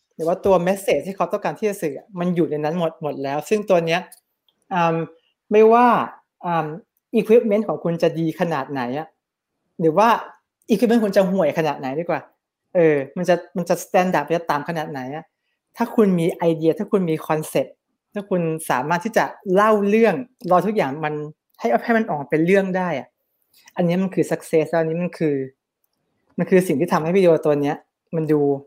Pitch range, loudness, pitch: 155-200 Hz, -20 LUFS, 175 Hz